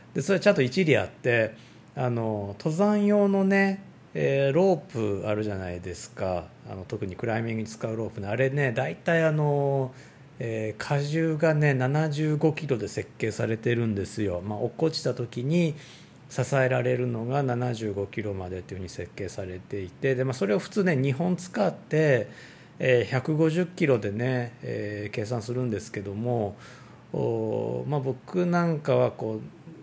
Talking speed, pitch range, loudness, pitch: 310 characters per minute, 110-155 Hz, -27 LUFS, 125 Hz